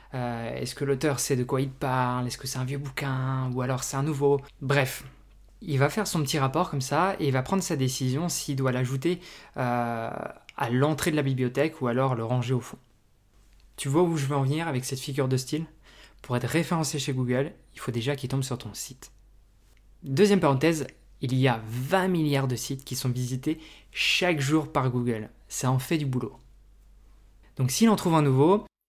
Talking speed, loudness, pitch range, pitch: 210 wpm, -27 LUFS, 125-150 Hz, 135 Hz